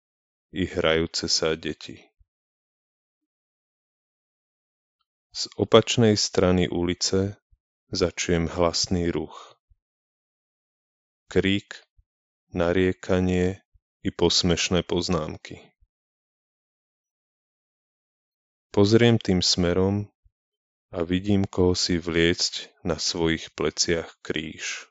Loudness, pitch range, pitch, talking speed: -24 LUFS, 85-100 Hz, 90 Hz, 65 wpm